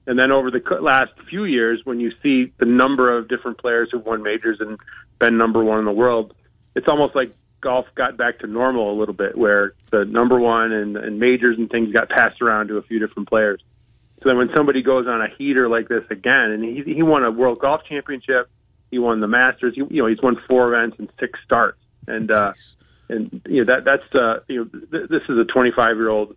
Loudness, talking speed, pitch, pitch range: -18 LUFS, 230 wpm, 115 Hz, 110-125 Hz